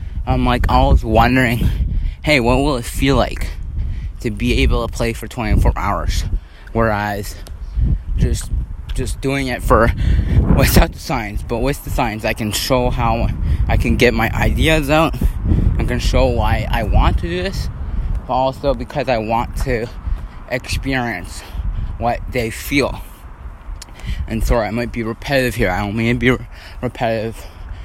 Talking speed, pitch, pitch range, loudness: 160 wpm, 110 Hz, 85-120 Hz, -18 LUFS